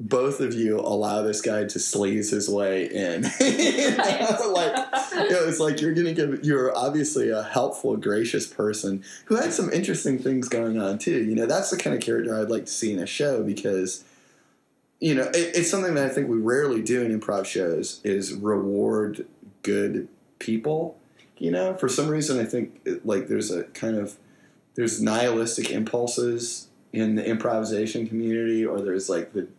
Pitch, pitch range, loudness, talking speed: 115 Hz, 105-145 Hz, -25 LUFS, 185 wpm